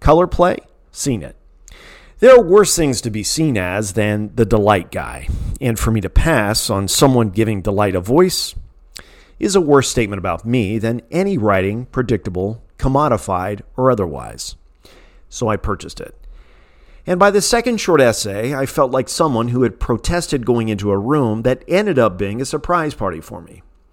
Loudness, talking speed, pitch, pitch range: -16 LUFS, 175 wpm, 115 Hz, 100-145 Hz